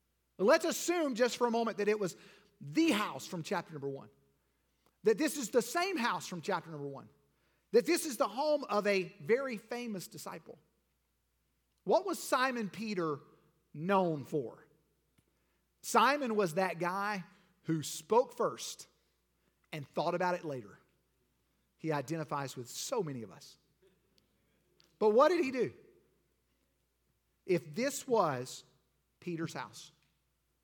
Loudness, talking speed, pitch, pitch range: -34 LUFS, 135 wpm, 185 Hz, 150-240 Hz